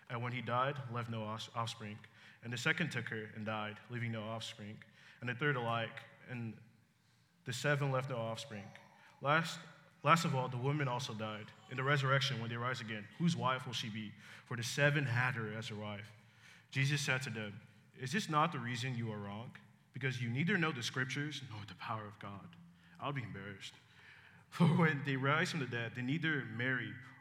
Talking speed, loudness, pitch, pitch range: 200 wpm, -37 LUFS, 125 Hz, 110-145 Hz